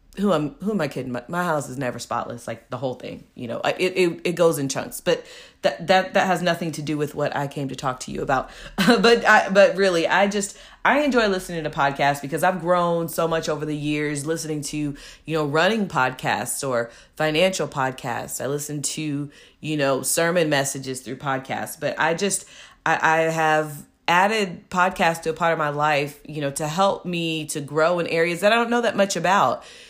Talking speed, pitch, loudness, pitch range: 220 wpm, 160 Hz, -22 LUFS, 145-185 Hz